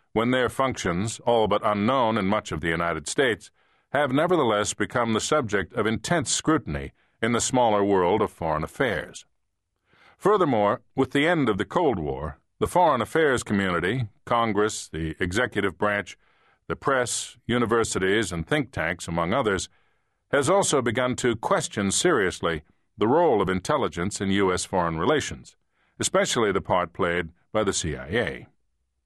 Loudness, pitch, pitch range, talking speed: -24 LUFS, 105 Hz, 95-120 Hz, 150 wpm